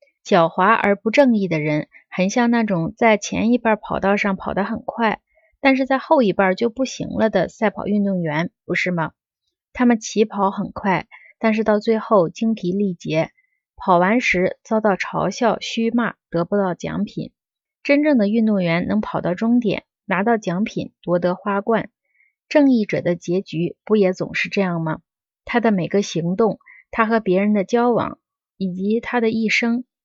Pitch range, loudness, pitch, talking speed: 185-235 Hz, -20 LUFS, 210 Hz, 245 characters per minute